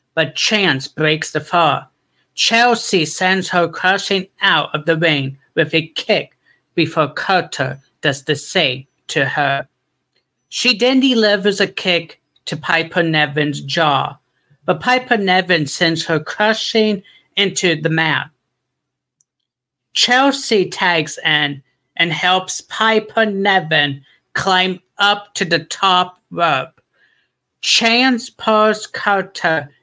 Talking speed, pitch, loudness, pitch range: 115 wpm, 170 Hz, -16 LUFS, 150-200 Hz